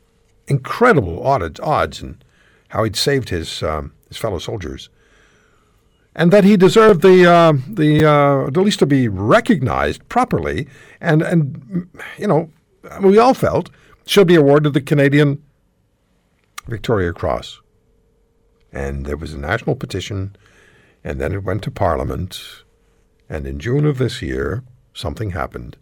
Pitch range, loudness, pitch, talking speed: 100-160 Hz, -16 LUFS, 140 Hz, 135 wpm